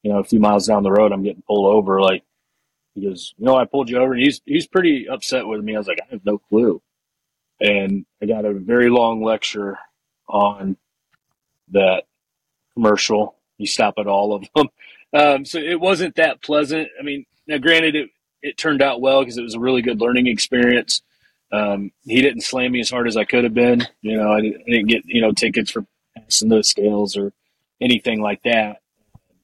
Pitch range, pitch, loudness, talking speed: 105-130 Hz, 115 Hz, -18 LUFS, 210 wpm